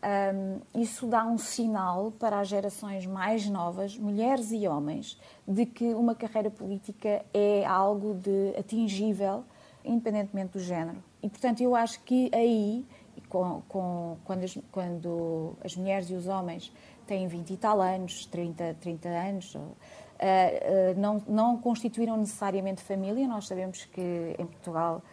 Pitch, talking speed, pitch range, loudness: 200 Hz, 140 wpm, 185-220 Hz, -30 LUFS